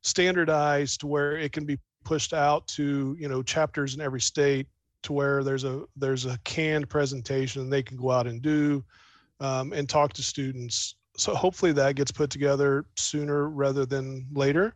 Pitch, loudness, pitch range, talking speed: 140 Hz, -27 LUFS, 135-150 Hz, 185 wpm